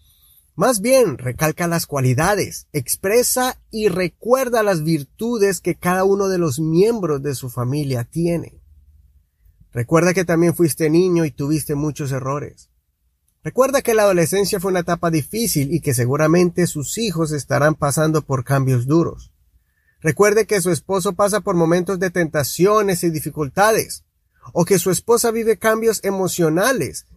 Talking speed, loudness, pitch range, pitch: 145 wpm, -18 LUFS, 140-195 Hz, 165 Hz